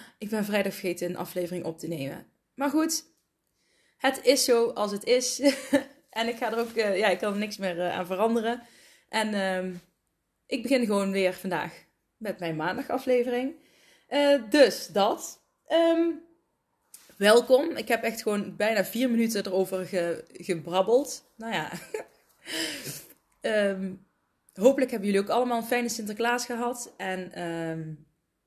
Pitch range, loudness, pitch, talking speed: 185-250 Hz, -27 LUFS, 220 Hz, 145 wpm